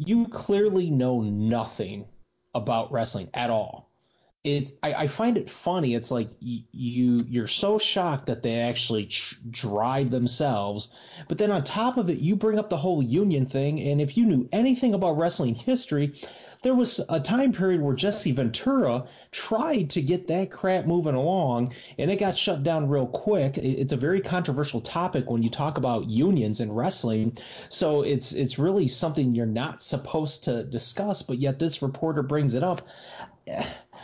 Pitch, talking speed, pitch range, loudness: 145 Hz, 175 wpm, 120-185 Hz, -26 LUFS